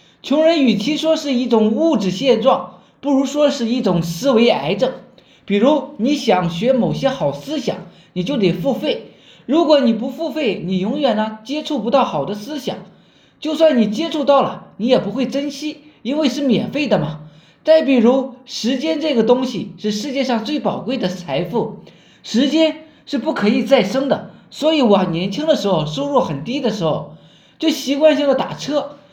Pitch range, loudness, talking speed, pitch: 205-290 Hz, -17 LUFS, 260 characters per minute, 255 Hz